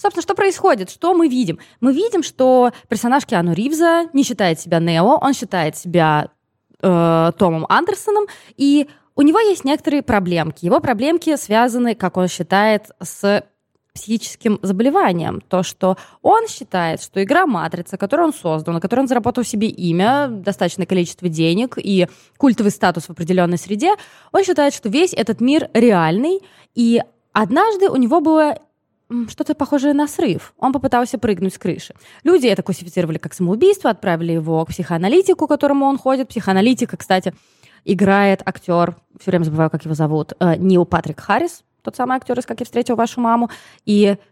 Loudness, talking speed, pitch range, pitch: -17 LUFS, 160 wpm, 180-280 Hz, 220 Hz